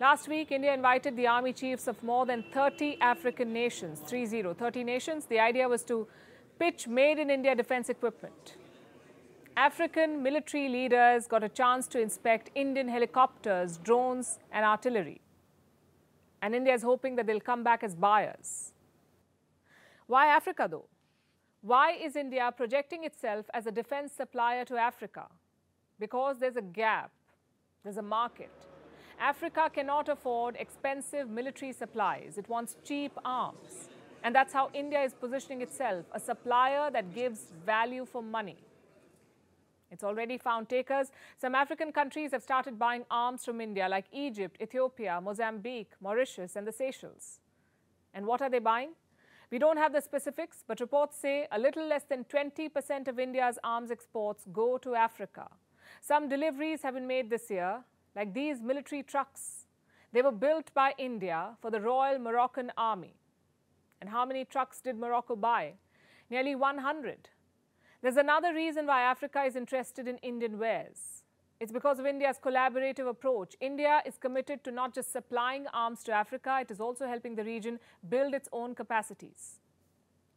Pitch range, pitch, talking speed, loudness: 230-275 Hz, 250 Hz, 155 wpm, -32 LUFS